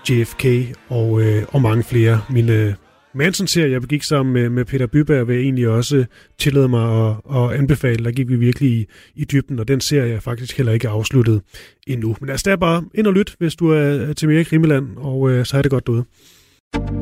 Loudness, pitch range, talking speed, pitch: -17 LUFS, 115-145 Hz, 220 wpm, 130 Hz